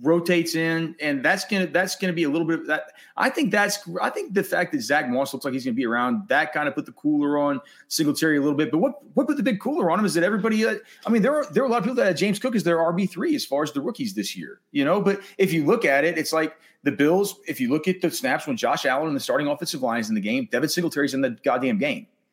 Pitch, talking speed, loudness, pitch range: 185 Hz, 310 wpm, -23 LUFS, 160-235 Hz